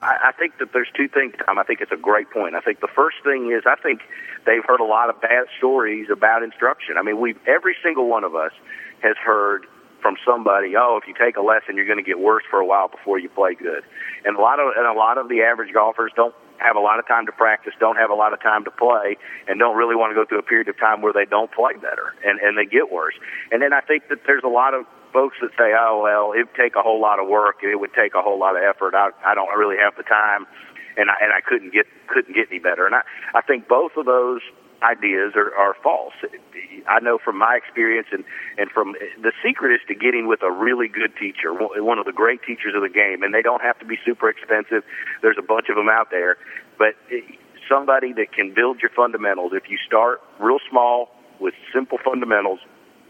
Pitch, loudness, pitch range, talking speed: 120 Hz, -19 LUFS, 110-140 Hz, 250 wpm